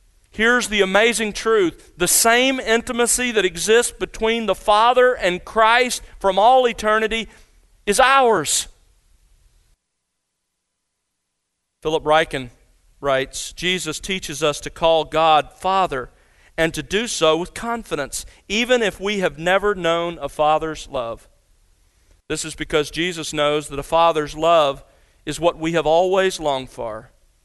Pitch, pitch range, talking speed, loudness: 165 Hz, 145-215 Hz, 130 wpm, -19 LUFS